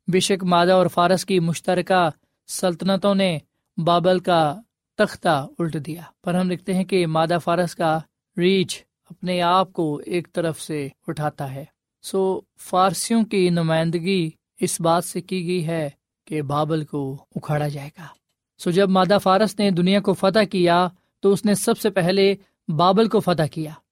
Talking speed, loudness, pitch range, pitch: 170 wpm, -21 LUFS, 160-190 Hz, 180 Hz